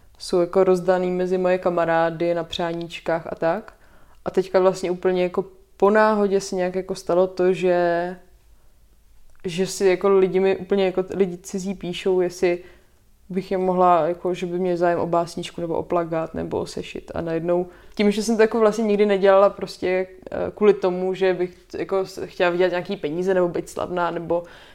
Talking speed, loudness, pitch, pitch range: 180 wpm, -22 LUFS, 185 Hz, 175-195 Hz